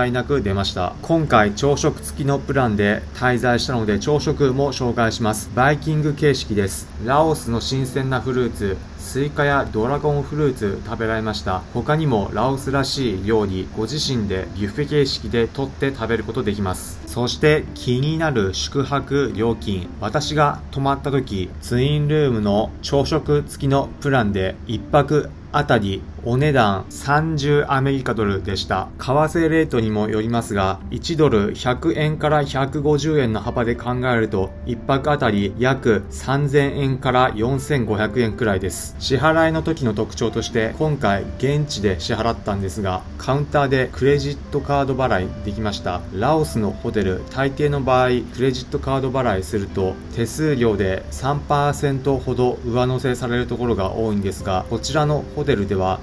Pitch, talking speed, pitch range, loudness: 125 Hz, 315 characters per minute, 105-140 Hz, -20 LUFS